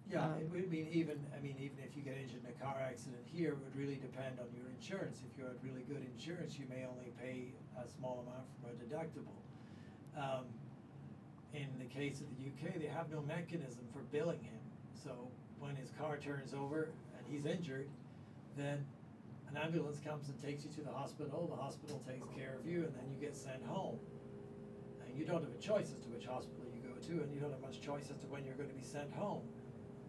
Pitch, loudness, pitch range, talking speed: 140 Hz, -46 LUFS, 130-150 Hz, 225 wpm